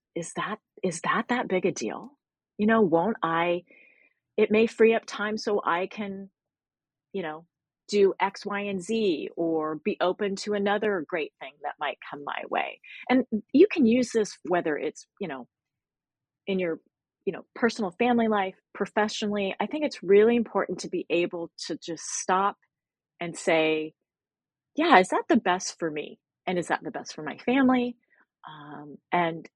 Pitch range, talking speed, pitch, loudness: 170-225 Hz, 175 wpm, 200 Hz, -27 LUFS